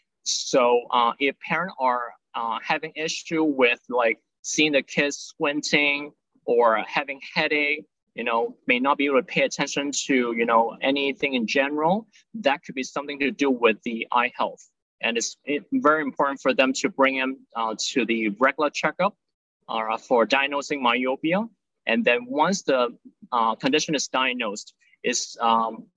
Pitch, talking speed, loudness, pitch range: 140 Hz, 160 wpm, -23 LUFS, 120-155 Hz